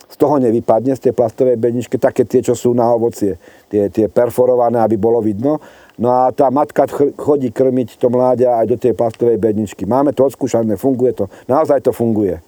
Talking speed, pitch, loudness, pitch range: 190 wpm, 120 Hz, -15 LUFS, 115-130 Hz